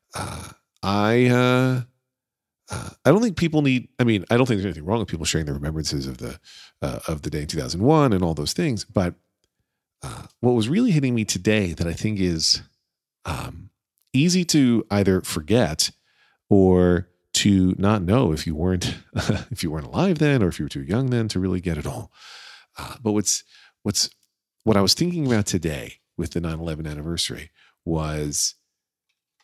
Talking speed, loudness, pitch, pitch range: 185 wpm, -22 LUFS, 100 Hz, 85-125 Hz